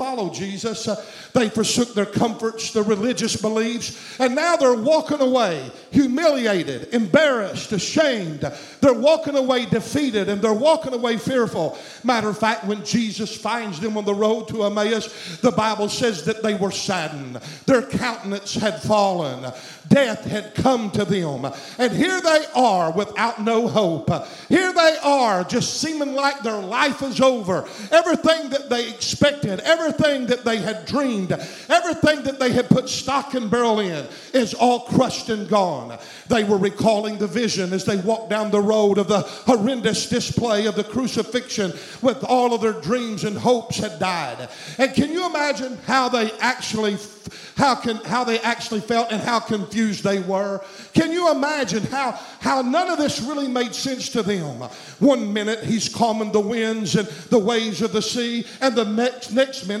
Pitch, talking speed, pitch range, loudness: 225 Hz, 170 wpm, 210-255 Hz, -21 LUFS